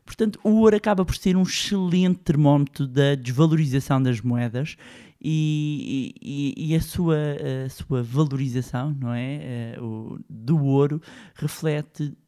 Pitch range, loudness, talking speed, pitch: 130-160 Hz, -23 LUFS, 130 wpm, 145 Hz